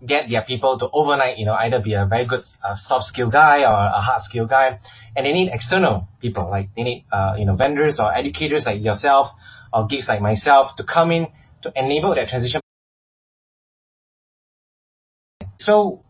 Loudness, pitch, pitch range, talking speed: -19 LUFS, 125 Hz, 105-140 Hz, 185 wpm